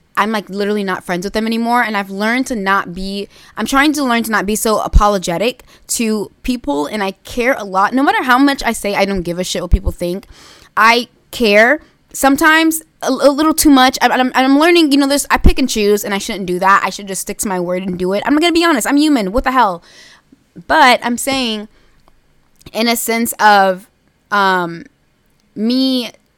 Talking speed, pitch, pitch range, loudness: 220 wpm, 225 Hz, 195-260 Hz, -14 LUFS